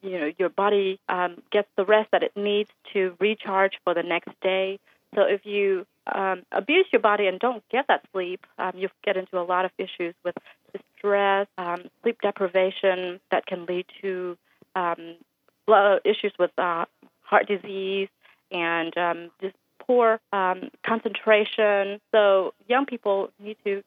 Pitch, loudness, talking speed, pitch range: 195 Hz, -24 LUFS, 160 wpm, 180-205 Hz